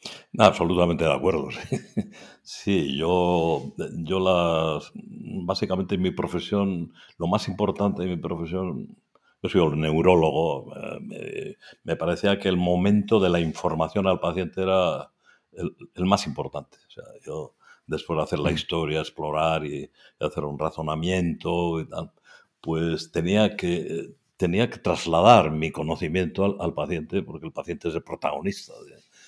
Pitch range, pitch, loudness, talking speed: 80-95 Hz, 85 Hz, -25 LUFS, 150 wpm